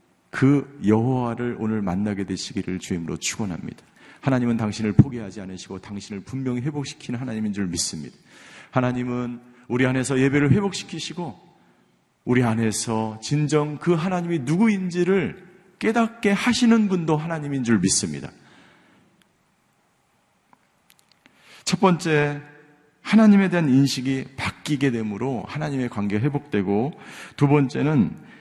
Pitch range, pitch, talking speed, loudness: 110-160 Hz, 135 Hz, 300 characters per minute, -22 LUFS